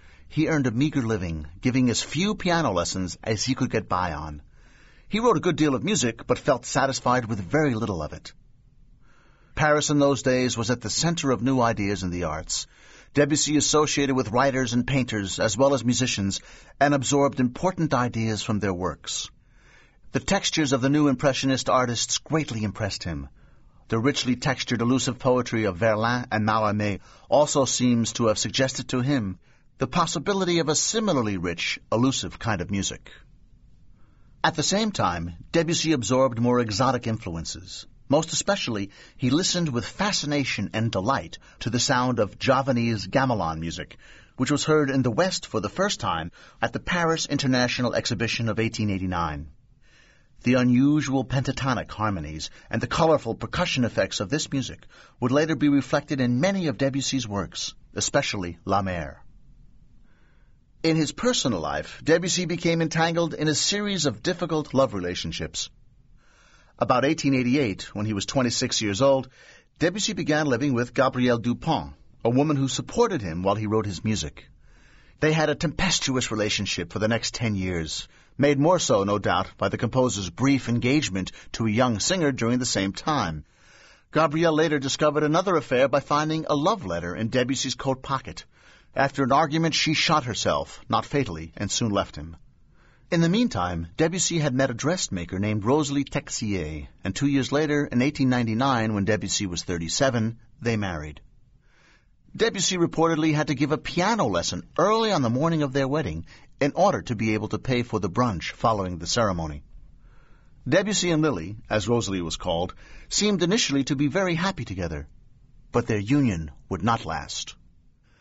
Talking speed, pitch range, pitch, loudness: 165 wpm, 105-150 Hz, 125 Hz, -24 LUFS